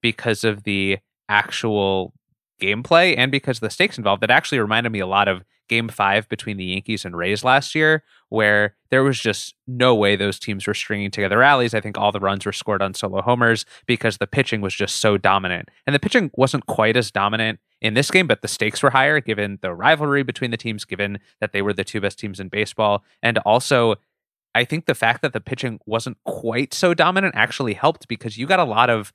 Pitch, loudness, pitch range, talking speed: 110 Hz, -19 LUFS, 100-125 Hz, 220 wpm